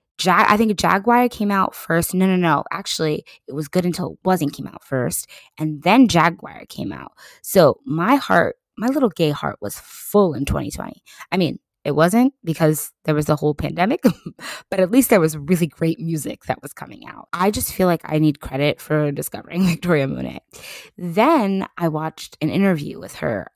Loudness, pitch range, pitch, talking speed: -19 LUFS, 155-195 Hz, 170 Hz, 195 wpm